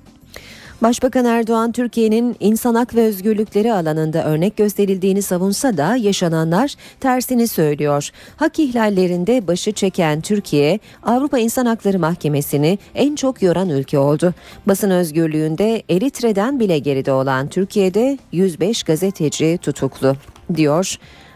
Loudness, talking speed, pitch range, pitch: -17 LUFS, 110 wpm, 155-230 Hz, 195 Hz